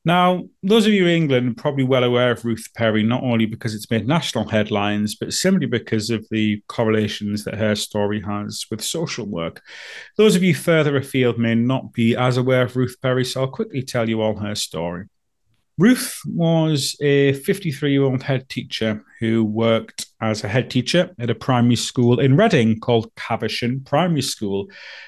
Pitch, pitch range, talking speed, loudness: 120 Hz, 110-140 Hz, 185 wpm, -20 LUFS